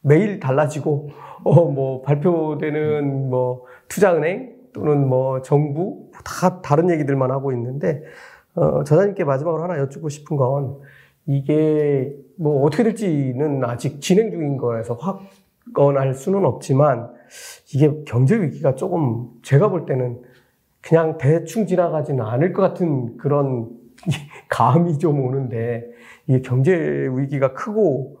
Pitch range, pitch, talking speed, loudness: 130-165 Hz, 145 Hz, 260 characters per minute, -20 LUFS